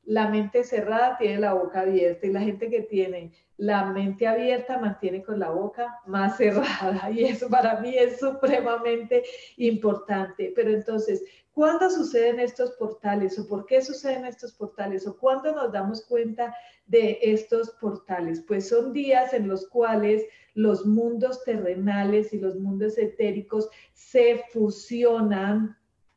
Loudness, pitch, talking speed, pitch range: -25 LUFS, 220 Hz, 145 wpm, 200-245 Hz